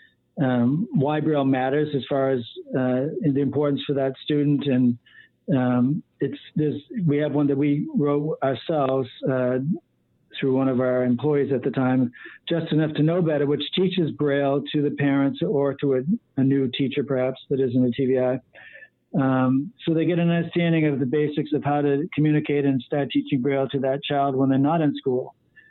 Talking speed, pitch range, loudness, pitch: 185 wpm, 135-150 Hz, -23 LUFS, 140 Hz